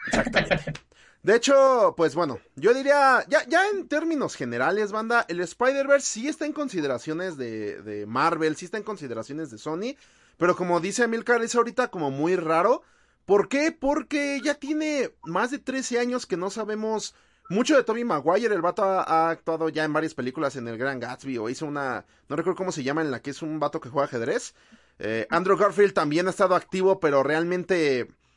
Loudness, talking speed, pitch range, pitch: -25 LUFS, 195 wpm, 155-250 Hz, 185 Hz